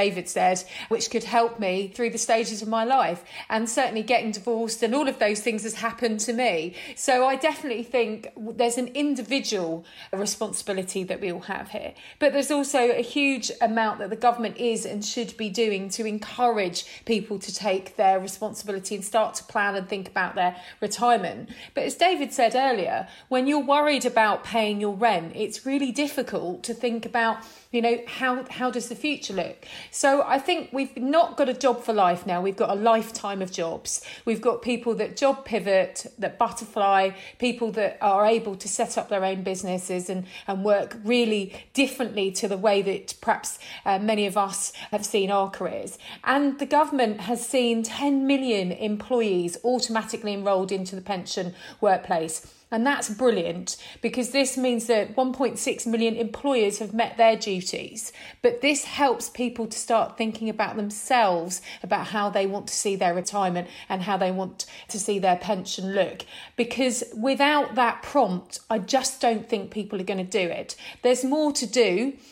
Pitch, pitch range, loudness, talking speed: 225 Hz, 200-245 Hz, -25 LUFS, 180 wpm